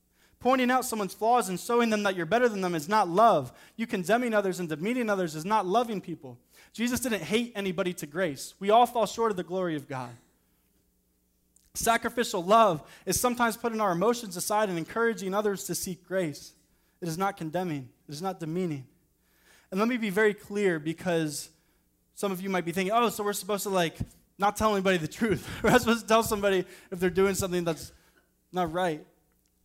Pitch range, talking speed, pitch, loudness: 165-220 Hz, 200 wpm, 195 Hz, -28 LUFS